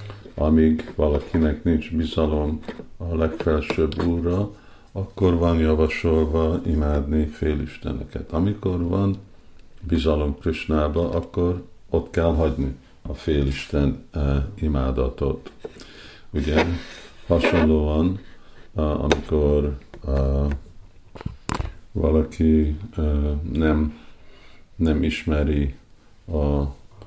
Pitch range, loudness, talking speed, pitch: 75-85 Hz, -23 LUFS, 80 wpm, 80 Hz